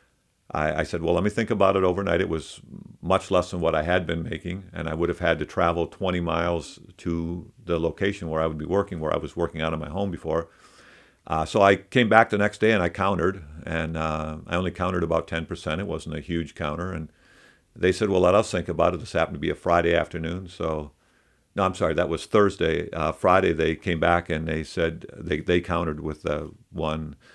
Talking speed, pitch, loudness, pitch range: 230 wpm, 85 Hz, -25 LUFS, 80-95 Hz